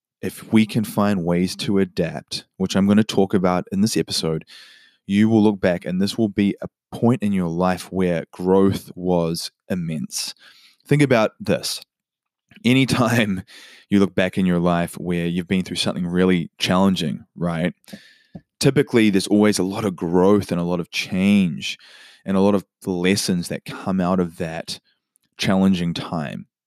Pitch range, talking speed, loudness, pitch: 90-105 Hz, 170 wpm, -20 LUFS, 95 Hz